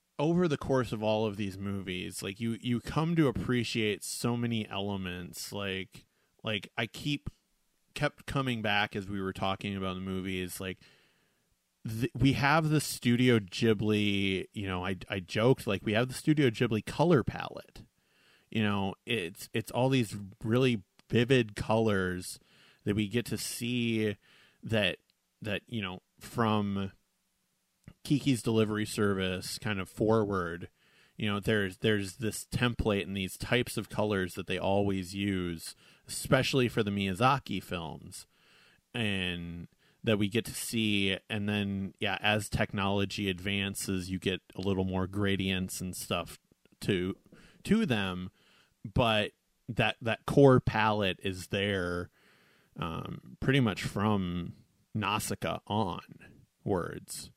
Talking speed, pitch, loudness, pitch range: 140 wpm, 105 Hz, -31 LUFS, 95-120 Hz